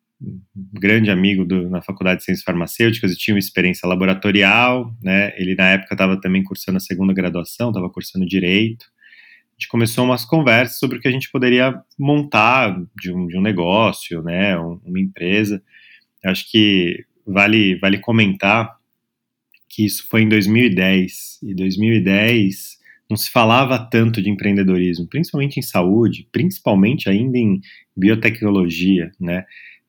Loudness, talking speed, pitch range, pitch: -17 LUFS, 150 wpm, 95-115 Hz, 100 Hz